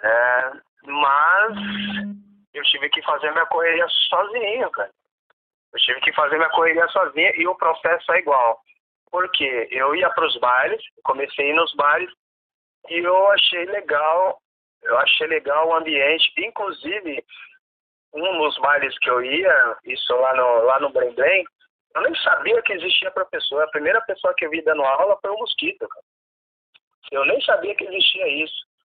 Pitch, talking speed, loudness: 200 Hz, 170 wpm, -19 LUFS